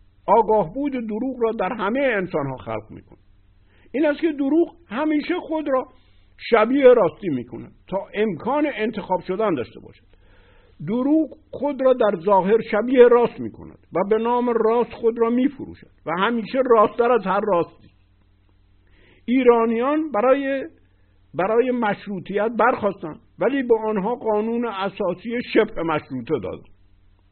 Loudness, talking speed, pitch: -21 LUFS, 135 wpm, 215 Hz